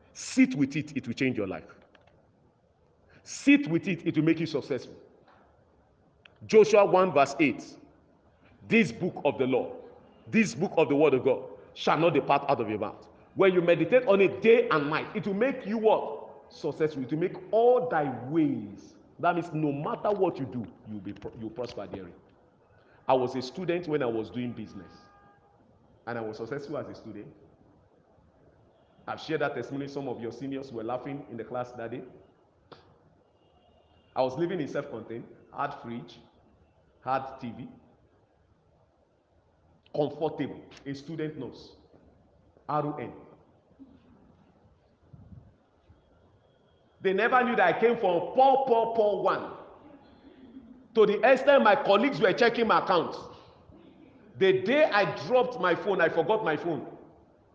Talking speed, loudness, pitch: 155 wpm, -27 LUFS, 155 Hz